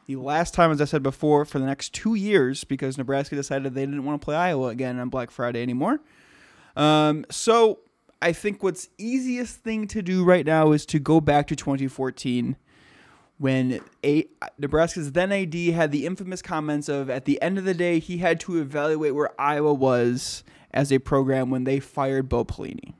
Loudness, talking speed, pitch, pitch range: -24 LUFS, 190 wpm, 150 Hz, 135-170 Hz